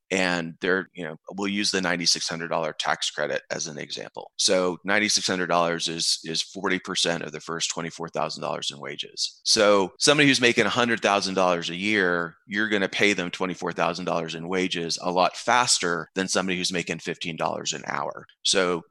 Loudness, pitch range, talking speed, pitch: -24 LUFS, 85-100 Hz, 160 wpm, 90 Hz